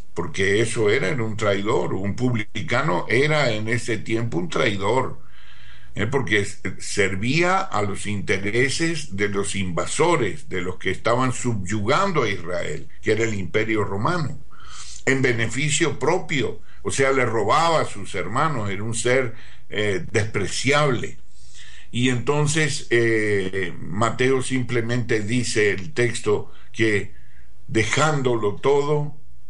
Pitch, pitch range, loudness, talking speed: 115 Hz, 100-130 Hz, -22 LUFS, 125 wpm